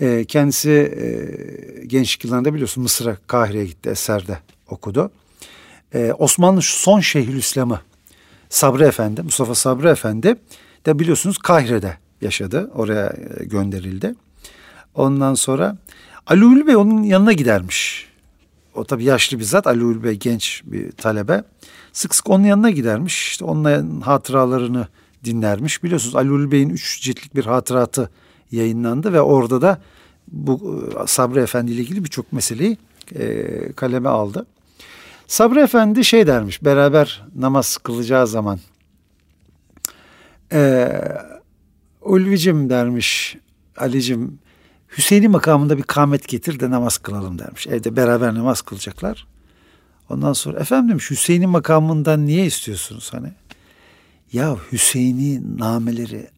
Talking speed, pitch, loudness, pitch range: 115 wpm, 130 Hz, -17 LUFS, 110-155 Hz